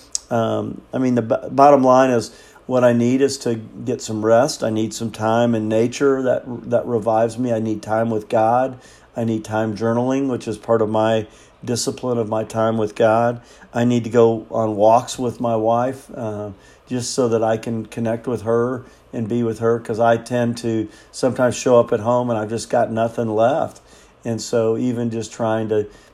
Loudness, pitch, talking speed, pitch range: -19 LUFS, 115 Hz, 205 wpm, 110-120 Hz